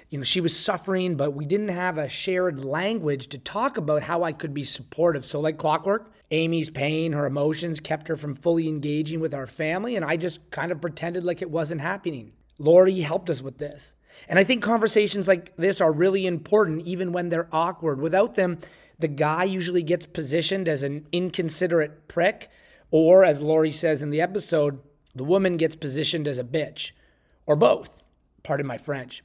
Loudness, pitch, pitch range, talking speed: -24 LUFS, 165 Hz, 150-180 Hz, 190 wpm